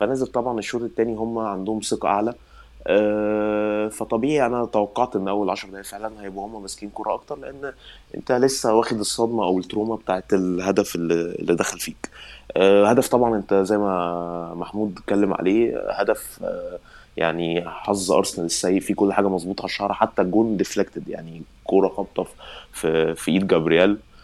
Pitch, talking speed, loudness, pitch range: 105 Hz, 150 wpm, -22 LUFS, 95-110 Hz